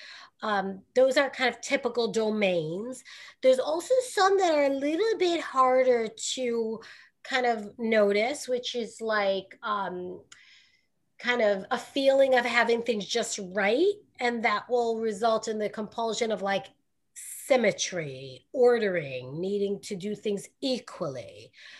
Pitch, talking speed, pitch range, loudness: 230 Hz, 135 wpm, 205-260 Hz, -27 LUFS